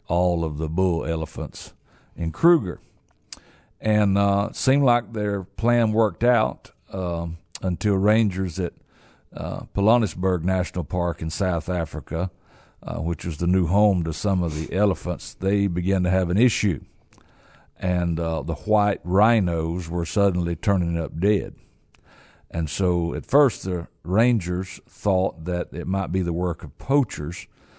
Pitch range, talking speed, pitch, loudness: 85-100 Hz, 150 wpm, 90 Hz, -23 LUFS